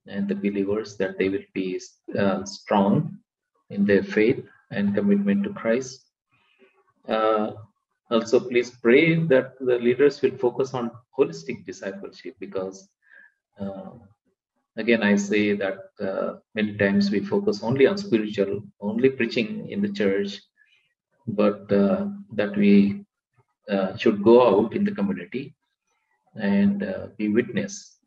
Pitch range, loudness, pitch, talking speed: 100-165 Hz, -23 LUFS, 115 Hz, 135 wpm